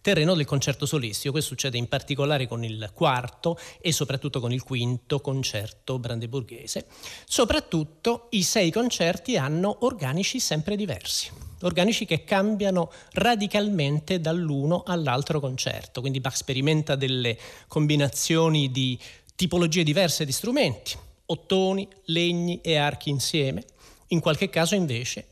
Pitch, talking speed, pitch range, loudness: 150 Hz, 125 wpm, 135-180 Hz, -25 LUFS